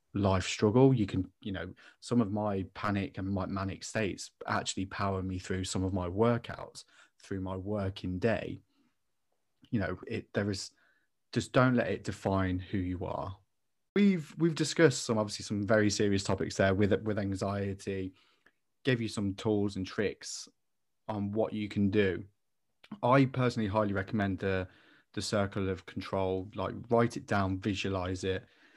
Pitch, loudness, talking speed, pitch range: 100 Hz, -32 LUFS, 165 wpm, 95-110 Hz